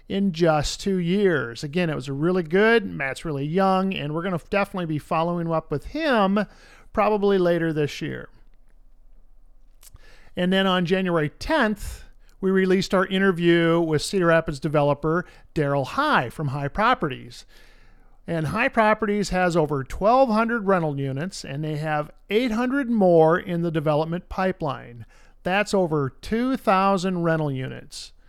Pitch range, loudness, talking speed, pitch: 155-195 Hz, -23 LUFS, 140 wpm, 175 Hz